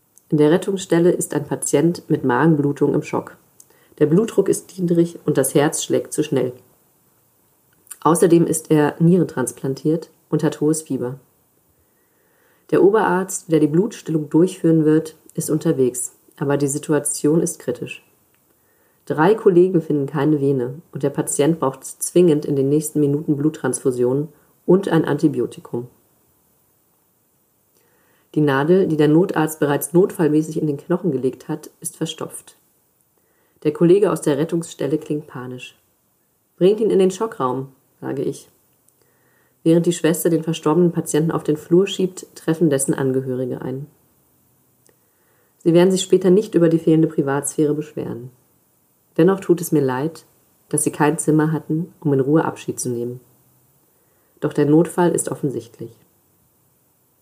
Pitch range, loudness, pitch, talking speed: 145-170 Hz, -19 LUFS, 155 Hz, 140 wpm